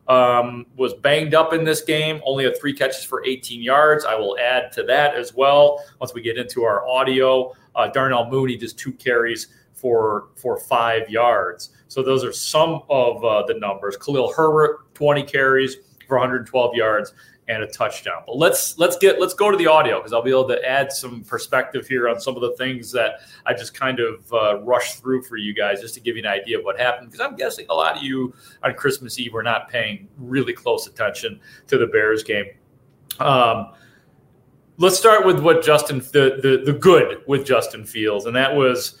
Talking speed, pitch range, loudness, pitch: 205 wpm, 125-150 Hz, -19 LUFS, 130 Hz